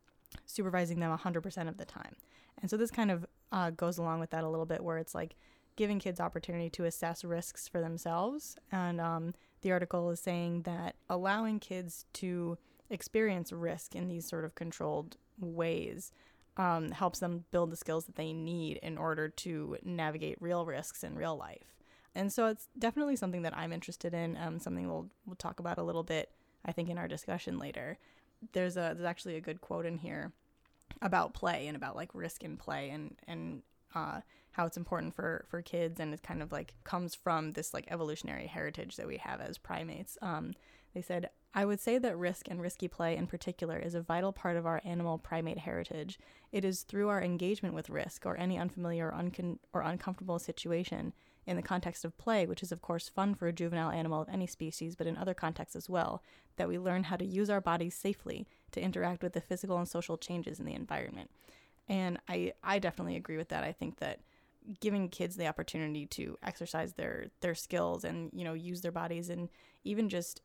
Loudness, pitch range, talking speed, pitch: -38 LUFS, 165-185 Hz, 205 wpm, 175 Hz